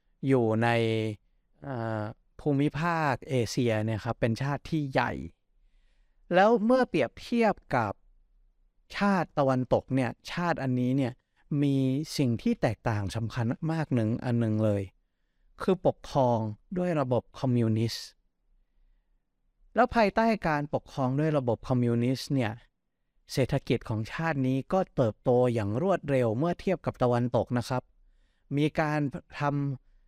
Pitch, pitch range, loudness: 130 Hz, 115-150 Hz, -28 LUFS